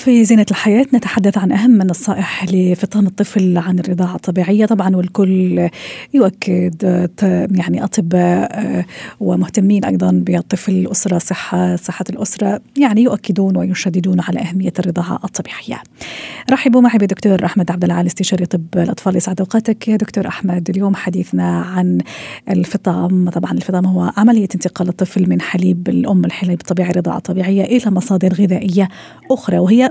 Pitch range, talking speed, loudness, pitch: 180-205 Hz, 135 wpm, -15 LUFS, 185 Hz